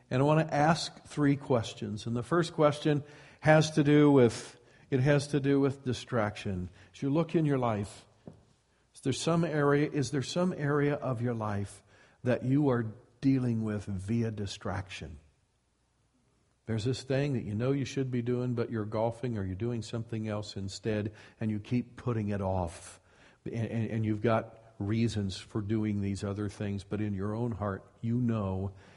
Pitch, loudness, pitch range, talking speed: 115 Hz, -31 LUFS, 105-135 Hz, 180 wpm